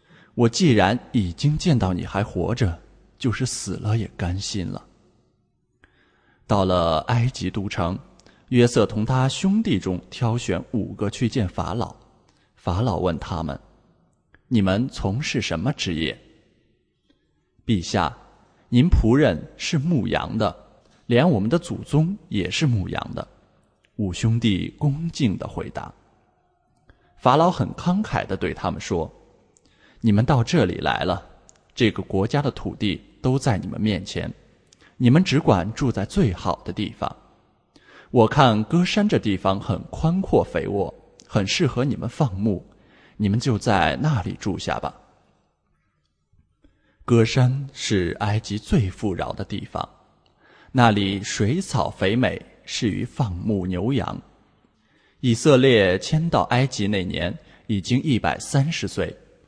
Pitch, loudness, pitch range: 115 Hz, -22 LUFS, 95-130 Hz